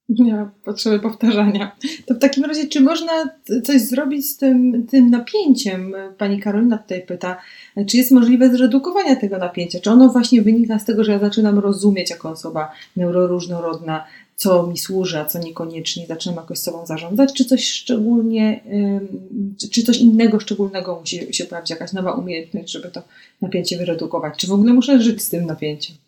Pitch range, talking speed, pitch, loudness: 180-245 Hz, 170 wpm, 205 Hz, -17 LUFS